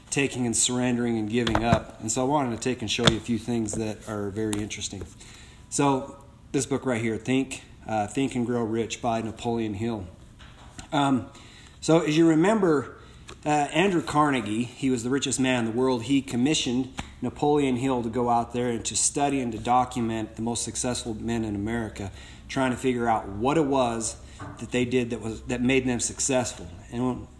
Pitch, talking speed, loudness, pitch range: 120 Hz, 195 wpm, -26 LUFS, 110-130 Hz